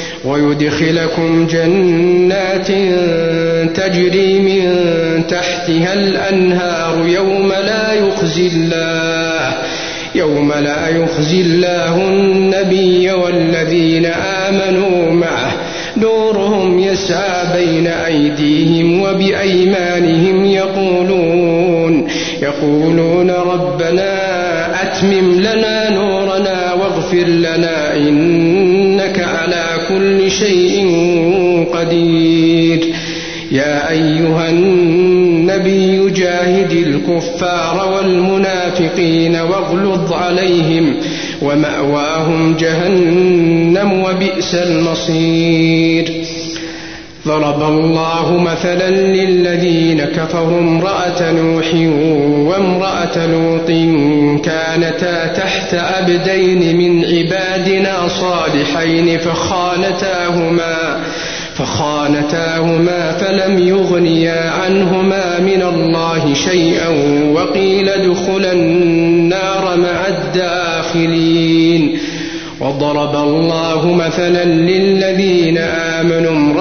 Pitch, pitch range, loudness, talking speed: 170 Hz, 165-185 Hz, -12 LUFS, 60 wpm